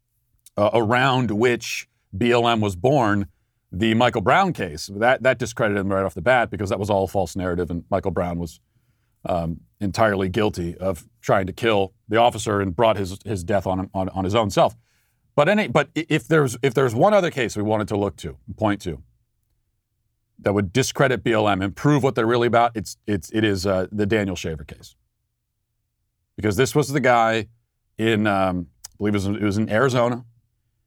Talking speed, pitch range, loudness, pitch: 190 wpm, 100-120 Hz, -21 LUFS, 110 Hz